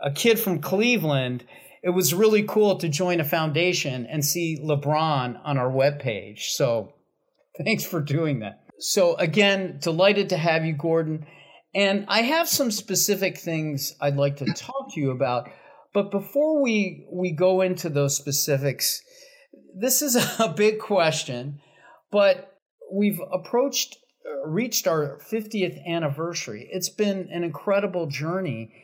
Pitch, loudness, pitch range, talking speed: 180 Hz, -24 LUFS, 150-205 Hz, 140 wpm